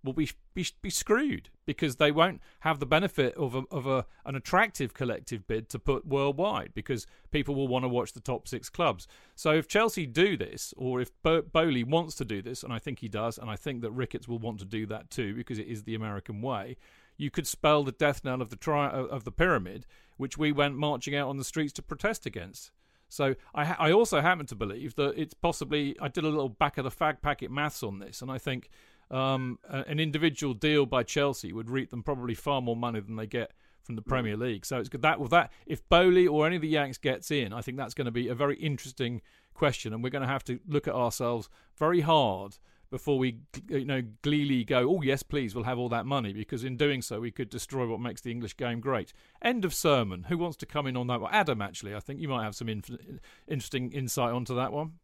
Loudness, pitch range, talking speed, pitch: -30 LUFS, 120-150 Hz, 240 wpm, 135 Hz